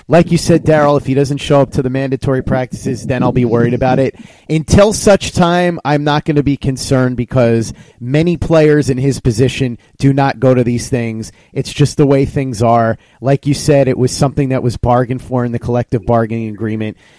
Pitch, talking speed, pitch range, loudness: 135 Hz, 215 wpm, 120-145 Hz, -13 LUFS